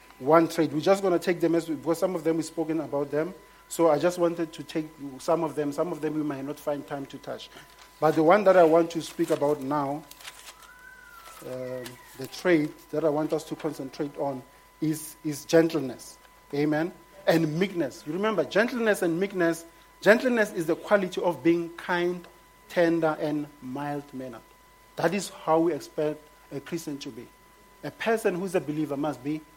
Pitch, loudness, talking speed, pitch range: 160 Hz, -27 LUFS, 195 wpm, 150-175 Hz